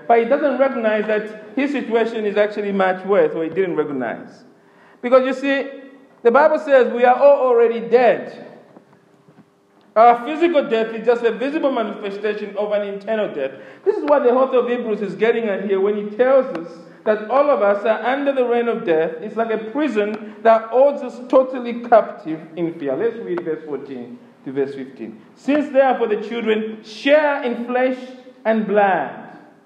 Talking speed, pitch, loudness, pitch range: 180 wpm, 230 Hz, -18 LUFS, 205-260 Hz